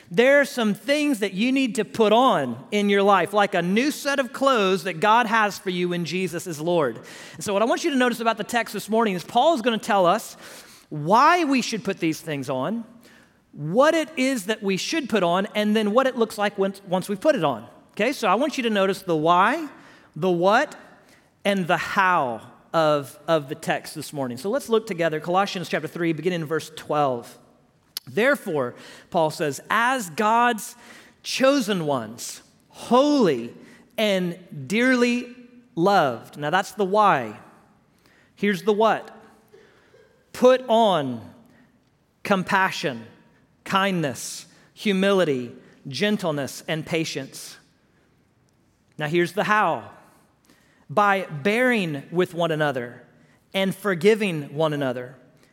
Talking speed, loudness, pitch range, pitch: 155 wpm, -22 LUFS, 165-230 Hz, 200 Hz